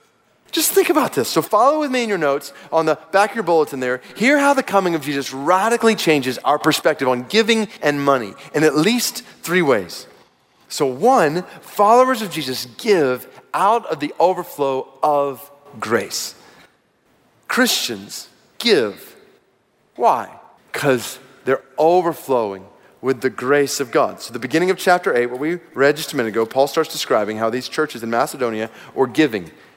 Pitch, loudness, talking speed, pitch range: 145 Hz, -18 LUFS, 165 wpm, 130-180 Hz